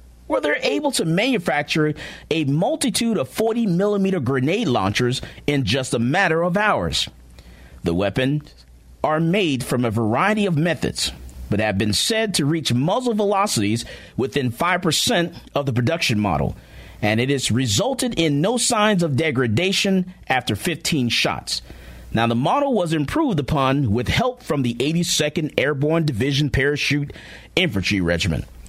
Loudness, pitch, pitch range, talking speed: -20 LUFS, 145 Hz, 115-175 Hz, 145 wpm